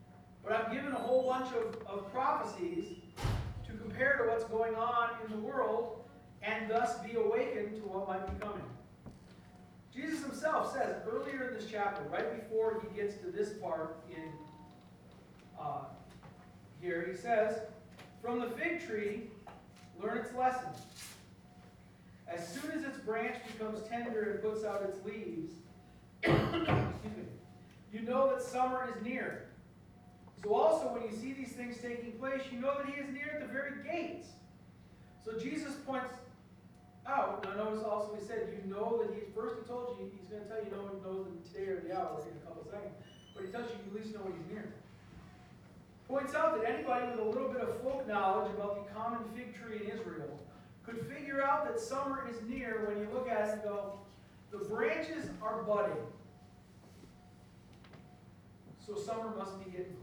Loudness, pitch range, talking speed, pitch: -38 LUFS, 205-250 Hz, 180 wpm, 225 Hz